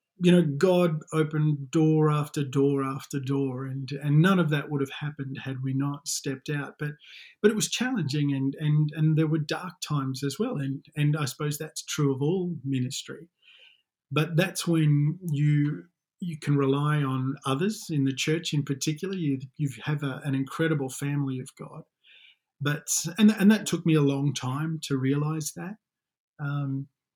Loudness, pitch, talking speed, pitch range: -27 LUFS, 150 Hz, 180 wpm, 140-160 Hz